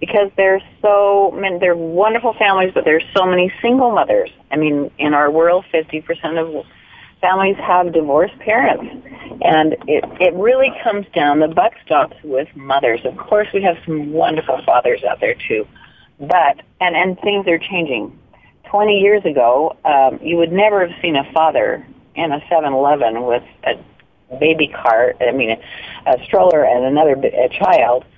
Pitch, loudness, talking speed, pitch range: 180 Hz, -15 LUFS, 165 wpm, 155-200 Hz